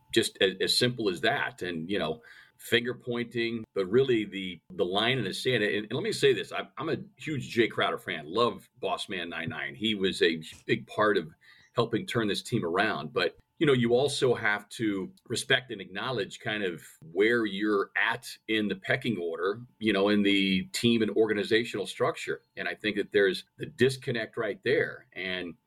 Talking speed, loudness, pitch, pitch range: 195 wpm, -29 LUFS, 110 Hz, 100-120 Hz